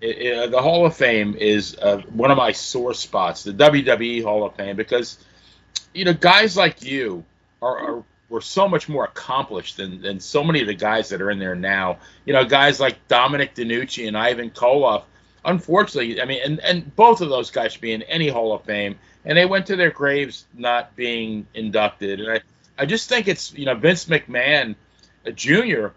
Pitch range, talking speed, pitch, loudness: 105-150 Hz, 205 wpm, 120 Hz, -19 LUFS